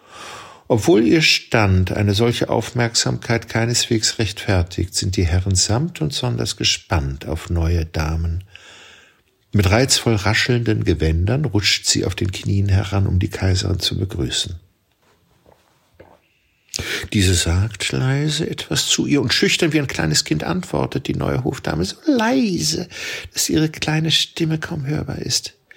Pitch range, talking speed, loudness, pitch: 95-135 Hz, 135 wpm, -19 LUFS, 110 Hz